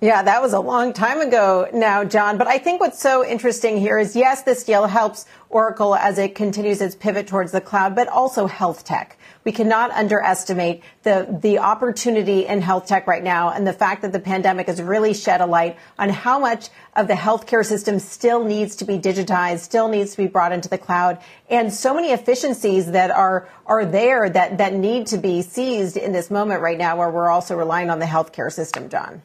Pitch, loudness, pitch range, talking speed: 200 Hz, -19 LUFS, 185-225 Hz, 215 wpm